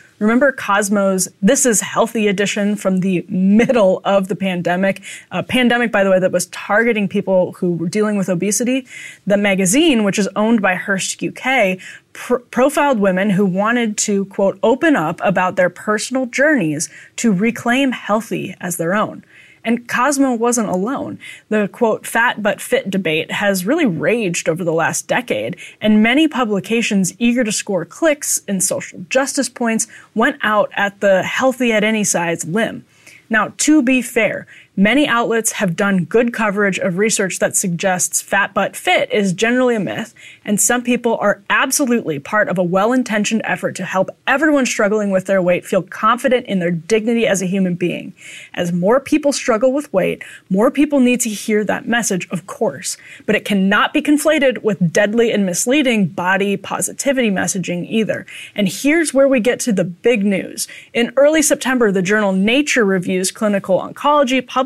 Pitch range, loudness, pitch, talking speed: 190-245 Hz, -16 LUFS, 210 Hz, 170 wpm